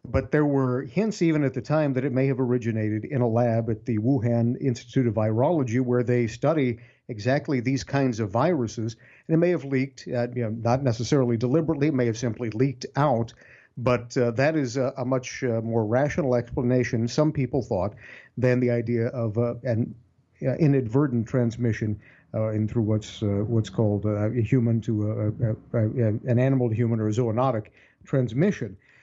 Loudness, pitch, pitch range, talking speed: -25 LUFS, 125 Hz, 115-135 Hz, 185 wpm